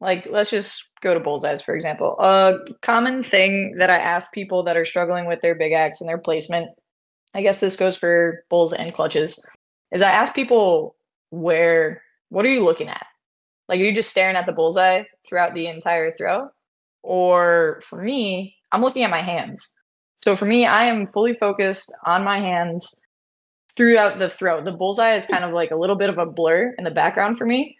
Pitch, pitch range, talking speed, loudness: 185 Hz, 170-210 Hz, 200 wpm, -19 LUFS